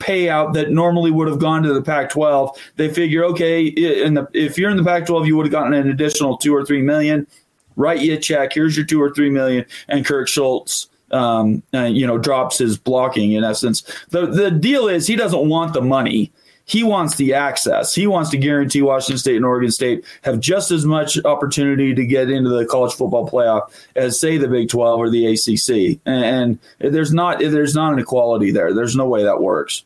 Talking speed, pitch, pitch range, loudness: 210 wpm, 145 Hz, 130-160 Hz, -17 LUFS